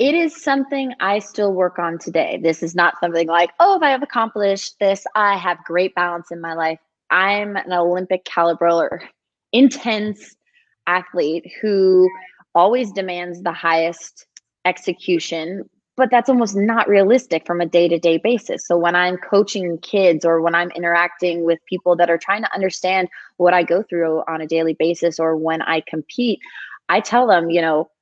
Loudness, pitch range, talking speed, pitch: -18 LUFS, 170-205 Hz, 180 wpm, 180 Hz